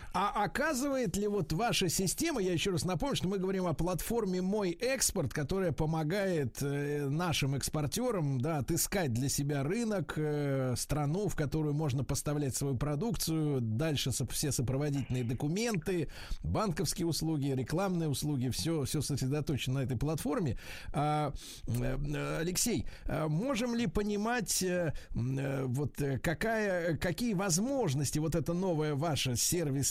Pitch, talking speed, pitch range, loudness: 155 Hz, 120 wpm, 140-185 Hz, -33 LUFS